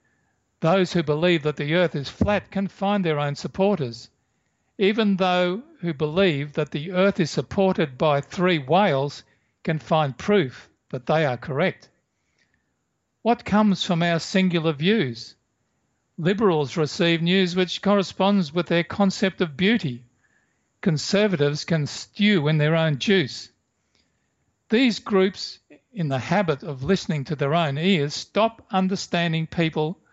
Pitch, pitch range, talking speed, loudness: 170 Hz, 150-195 Hz, 135 wpm, -23 LUFS